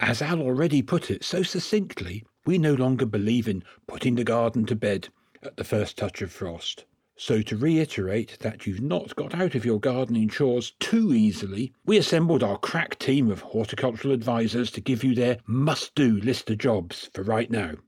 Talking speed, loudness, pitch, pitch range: 190 wpm, -25 LUFS, 125 Hz, 110-150 Hz